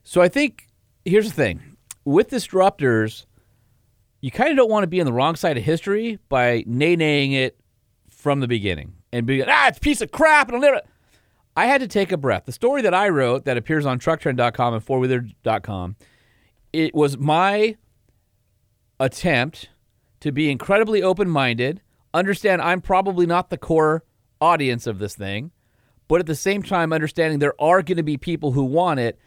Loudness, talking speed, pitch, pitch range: -20 LUFS, 180 wpm, 140 Hz, 120-180 Hz